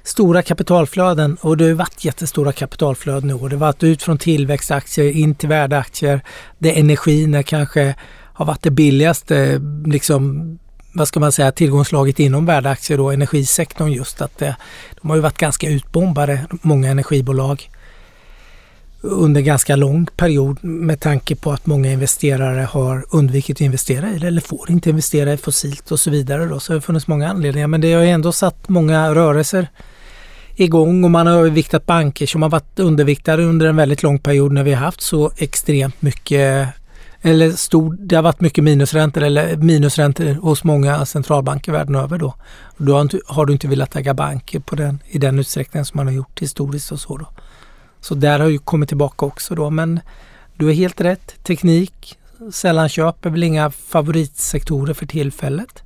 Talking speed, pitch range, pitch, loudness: 180 wpm, 140-165 Hz, 150 Hz, -16 LUFS